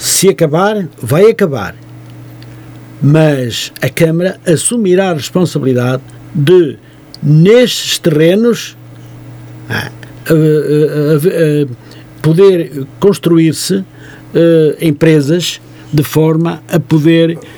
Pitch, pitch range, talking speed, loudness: 155 Hz, 130-170 Hz, 70 wpm, -11 LUFS